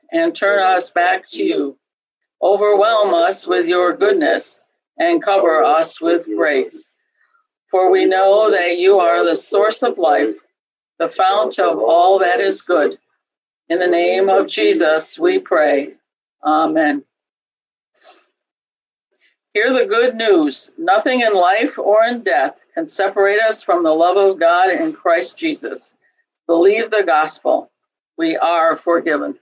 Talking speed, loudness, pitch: 140 wpm, -15 LUFS, 210 Hz